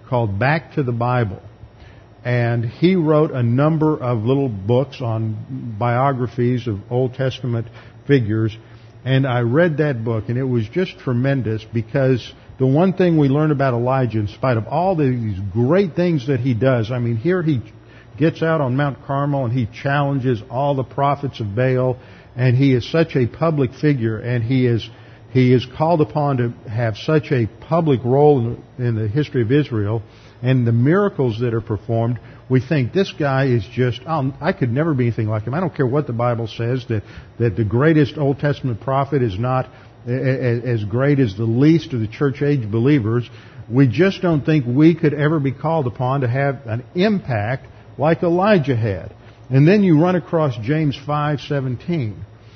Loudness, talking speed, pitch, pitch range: -19 LUFS, 185 wpm, 130 Hz, 115-145 Hz